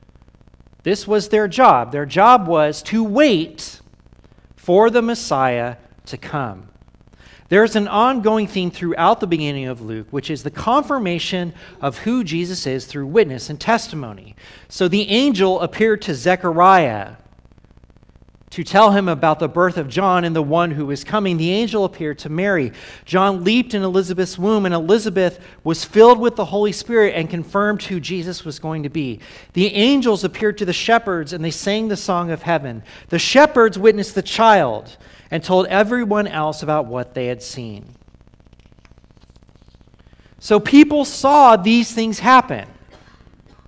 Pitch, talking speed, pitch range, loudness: 185 Hz, 155 wpm, 150-215 Hz, -17 LUFS